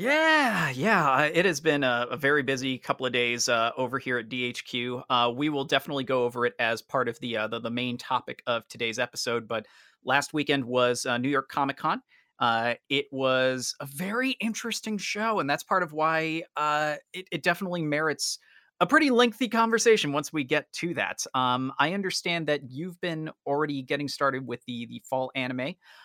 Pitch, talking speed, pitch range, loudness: 140 Hz, 195 wpm, 125-170 Hz, -27 LUFS